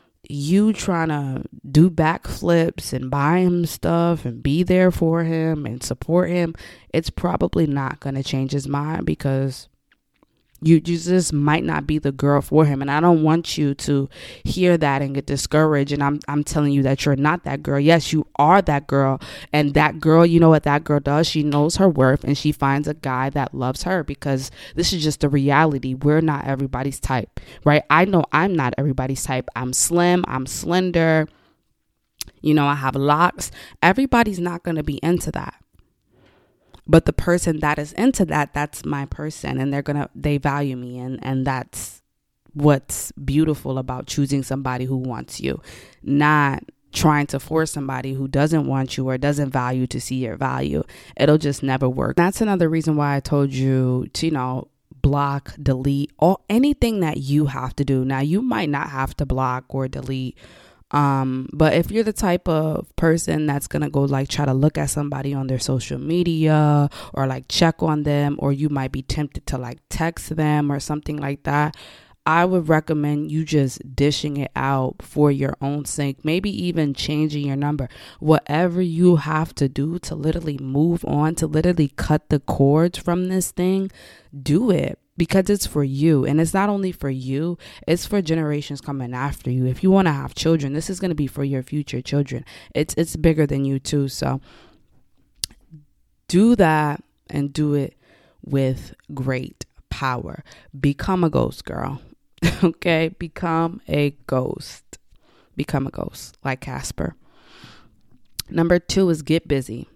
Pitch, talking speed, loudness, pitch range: 145 Hz, 180 wpm, -20 LUFS, 135-165 Hz